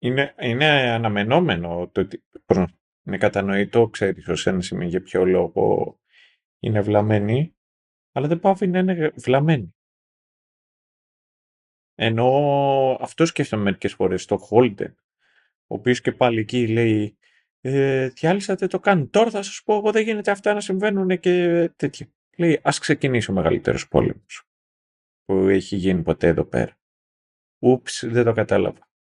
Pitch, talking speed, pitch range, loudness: 125 Hz, 140 wpm, 105-165 Hz, -21 LUFS